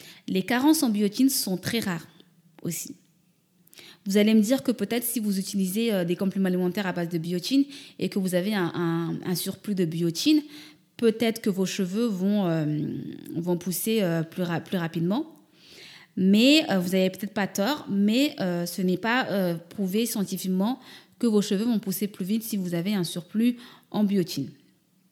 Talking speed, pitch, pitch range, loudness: 180 wpm, 195 Hz, 175-225 Hz, -26 LUFS